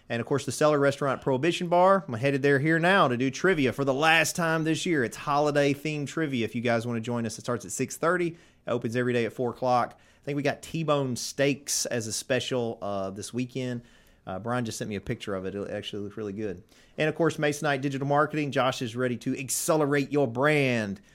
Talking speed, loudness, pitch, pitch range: 240 wpm, -27 LUFS, 135 Hz, 120-150 Hz